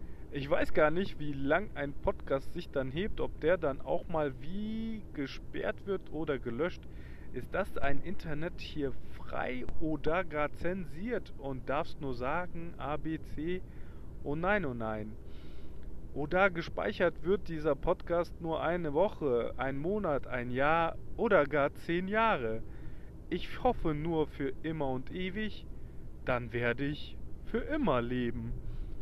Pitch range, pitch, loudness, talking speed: 125-175 Hz, 150 Hz, -34 LUFS, 145 wpm